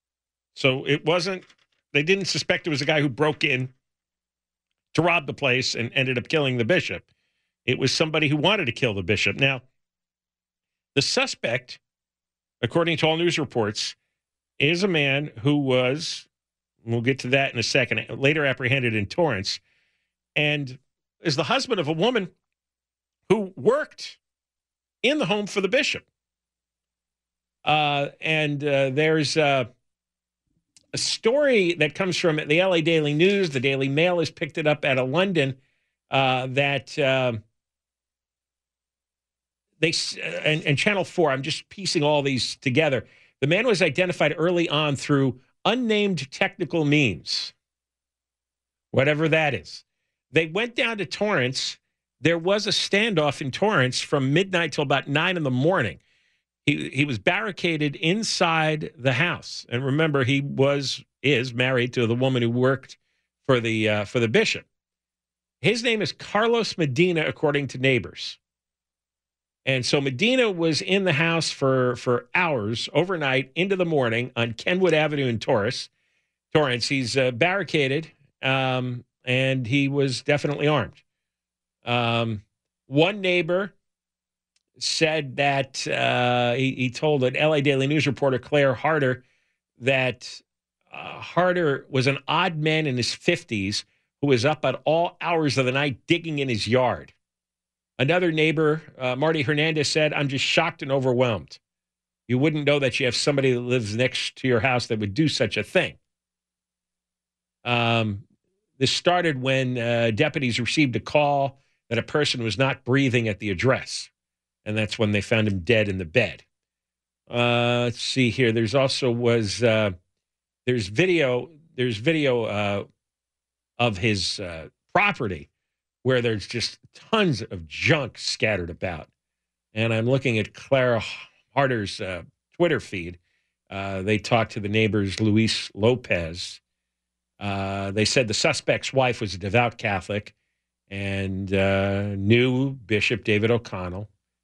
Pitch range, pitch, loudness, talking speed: 105-150 Hz, 130 Hz, -23 LUFS, 150 wpm